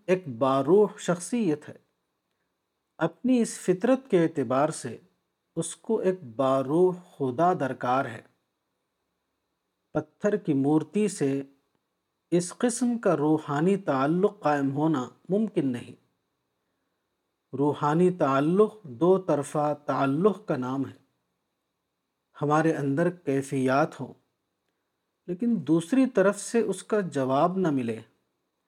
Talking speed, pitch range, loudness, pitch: 105 wpm, 140-190 Hz, -26 LUFS, 160 Hz